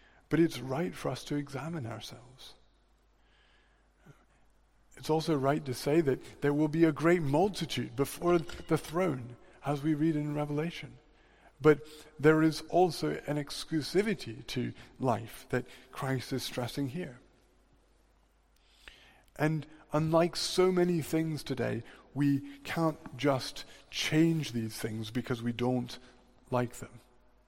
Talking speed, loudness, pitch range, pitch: 125 wpm, -32 LUFS, 125-160 Hz, 145 Hz